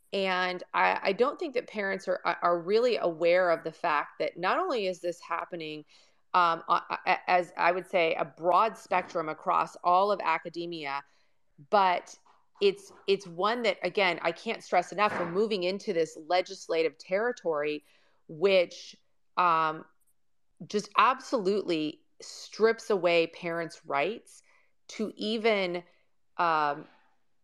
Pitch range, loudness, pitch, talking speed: 170-210 Hz, -29 LUFS, 180 Hz, 130 wpm